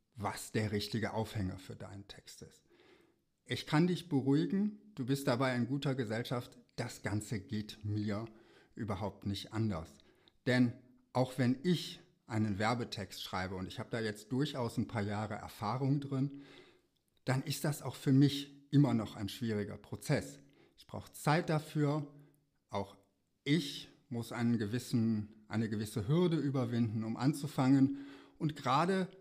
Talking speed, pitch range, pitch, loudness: 145 wpm, 105-140 Hz, 125 Hz, -36 LUFS